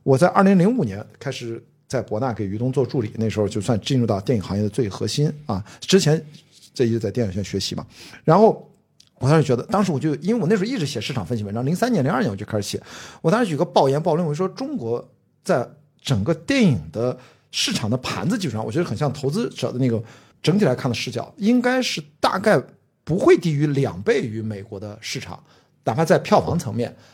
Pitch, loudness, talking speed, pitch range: 135 Hz, -21 LUFS, 340 characters per minute, 115-165 Hz